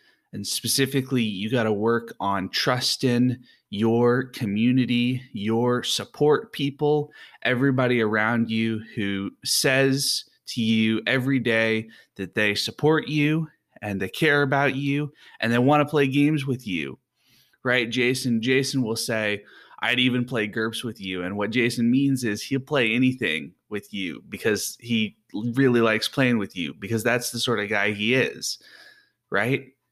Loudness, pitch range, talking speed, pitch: -23 LUFS, 110-135 Hz, 150 wpm, 120 Hz